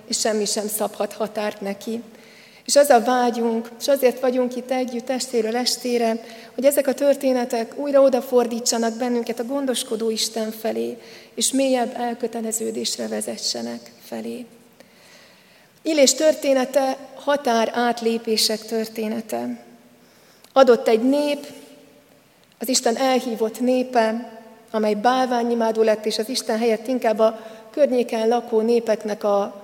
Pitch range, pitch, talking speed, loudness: 220-250 Hz, 230 Hz, 115 wpm, -21 LUFS